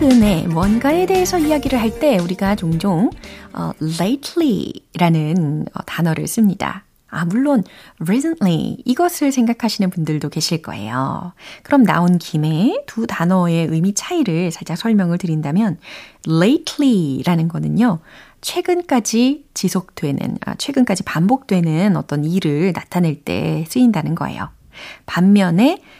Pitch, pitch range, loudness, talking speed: 190 Hz, 165-250 Hz, -17 LUFS, 315 characters per minute